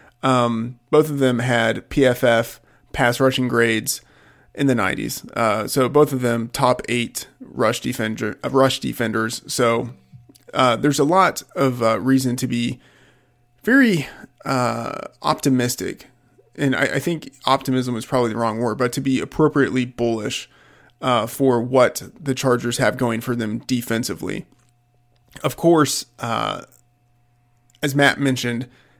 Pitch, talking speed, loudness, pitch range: 125 Hz, 145 wpm, -20 LUFS, 120-135 Hz